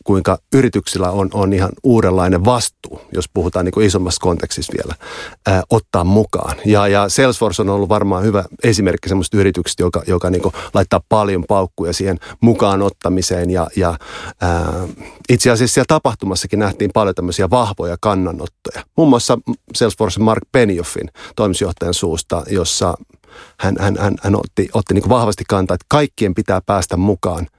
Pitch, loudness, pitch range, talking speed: 100 Hz, -16 LUFS, 90-105 Hz, 150 wpm